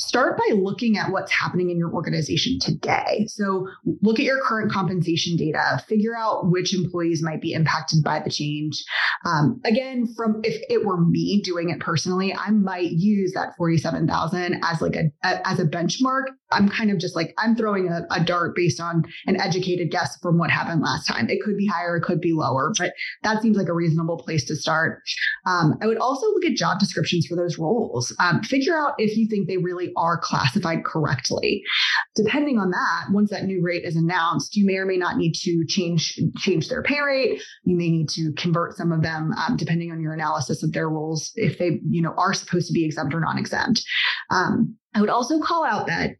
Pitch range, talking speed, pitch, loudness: 165-215 Hz, 215 wpm, 180 Hz, -22 LUFS